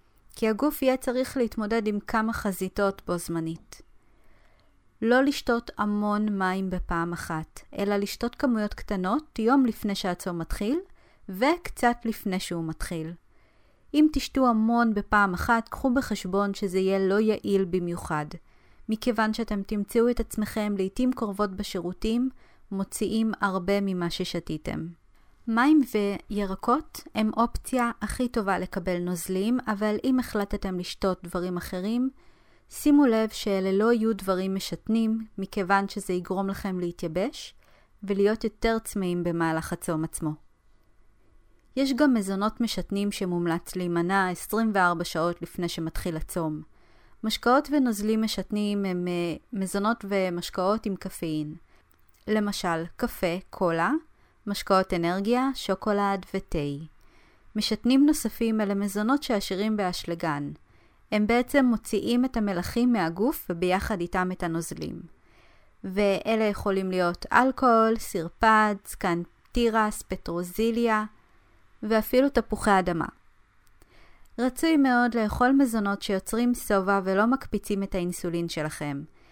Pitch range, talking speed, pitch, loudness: 180-230 Hz, 110 wpm, 200 Hz, -26 LUFS